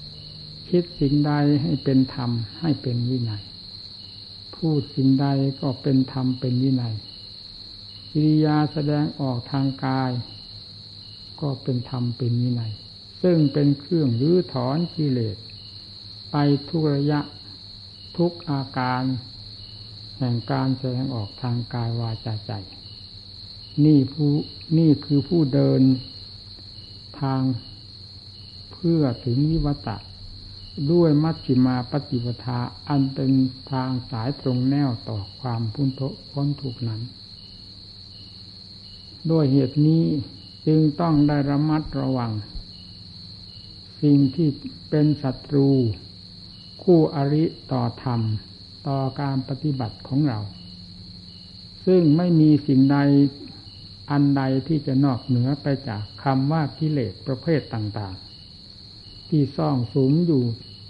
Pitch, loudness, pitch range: 125 Hz, -23 LUFS, 100-140 Hz